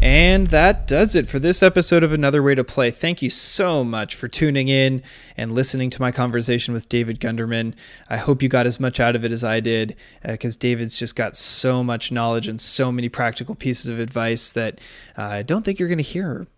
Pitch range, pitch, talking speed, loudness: 115-145 Hz, 125 Hz, 230 wpm, -19 LUFS